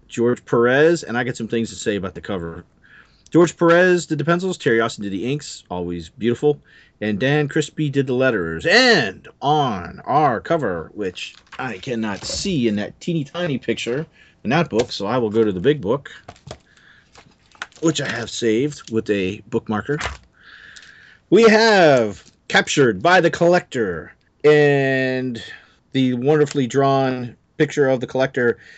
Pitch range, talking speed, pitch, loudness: 110-150 Hz, 155 wpm, 130 Hz, -19 LUFS